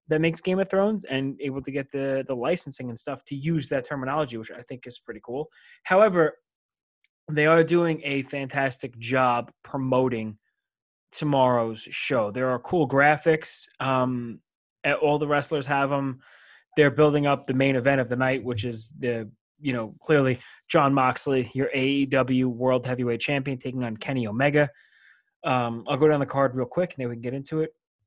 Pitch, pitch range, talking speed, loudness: 135 Hz, 125-150 Hz, 180 wpm, -25 LUFS